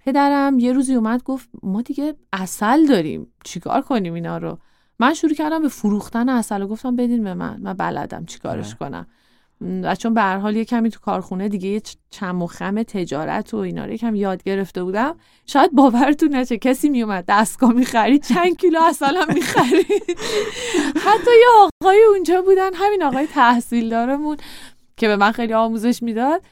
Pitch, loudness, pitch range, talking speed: 245 Hz, -18 LUFS, 210-300 Hz, 180 wpm